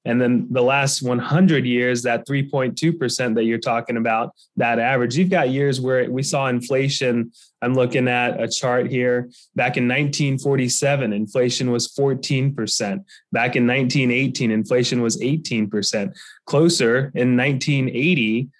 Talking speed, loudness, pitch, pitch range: 135 wpm, -20 LUFS, 125 Hz, 120-140 Hz